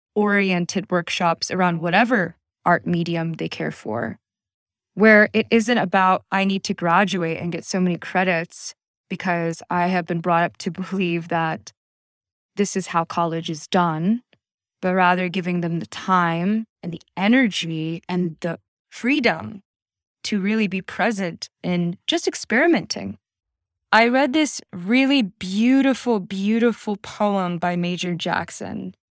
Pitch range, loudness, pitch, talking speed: 170-210 Hz, -21 LUFS, 180 Hz, 135 wpm